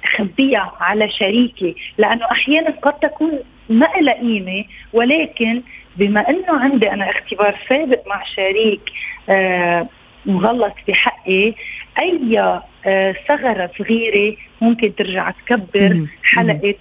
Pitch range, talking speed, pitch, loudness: 200-245 Hz, 95 wpm, 215 Hz, -16 LUFS